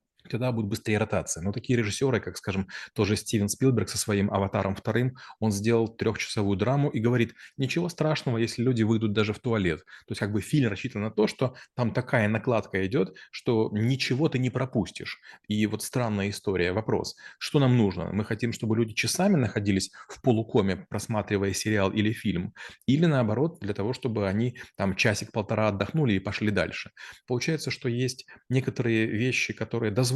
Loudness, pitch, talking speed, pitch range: -27 LUFS, 110 Hz, 175 wpm, 105-125 Hz